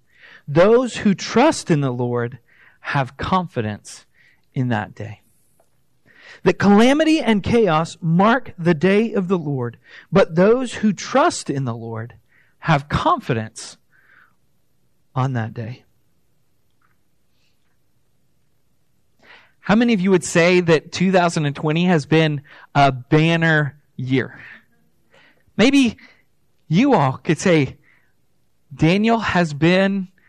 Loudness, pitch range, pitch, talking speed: -18 LUFS, 130-190 Hz, 160 Hz, 105 wpm